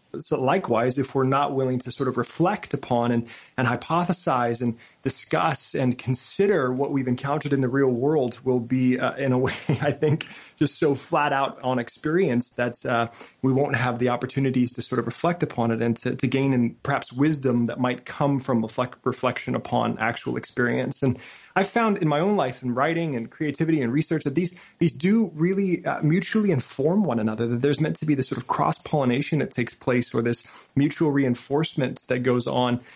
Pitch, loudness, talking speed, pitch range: 135 Hz, -24 LUFS, 200 wpm, 125-150 Hz